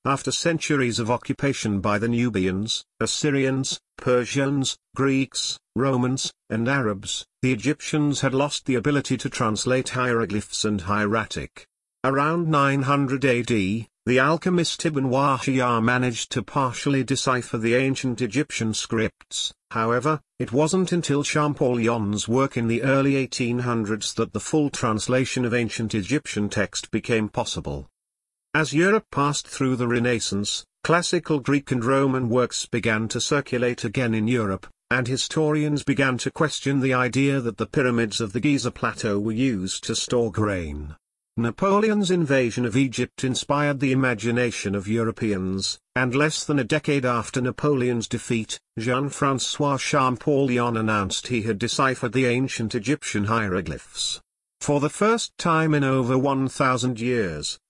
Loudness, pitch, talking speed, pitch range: -23 LUFS, 125 Hz, 135 wpm, 115-140 Hz